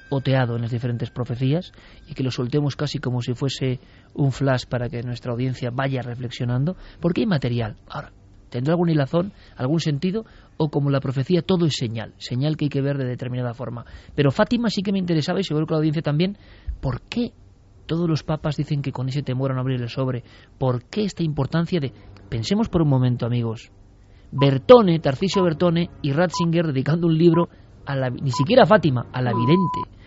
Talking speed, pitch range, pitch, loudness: 195 wpm, 125-165 Hz, 135 Hz, -22 LUFS